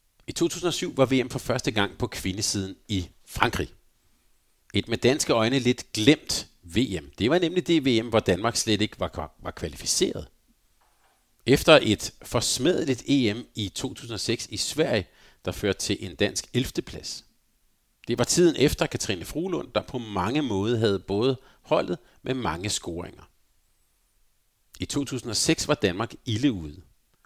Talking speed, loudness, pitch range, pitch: 145 wpm, -25 LUFS, 95-130 Hz, 115 Hz